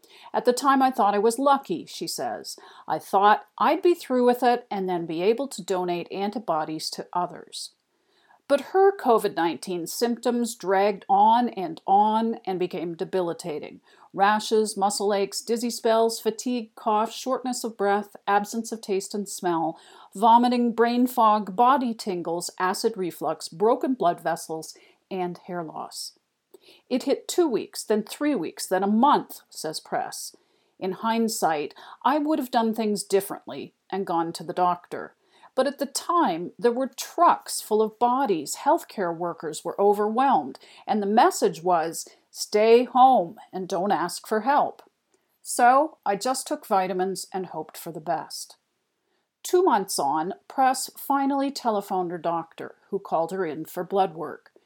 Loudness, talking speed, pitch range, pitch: -24 LUFS, 155 wpm, 190-265 Hz, 225 Hz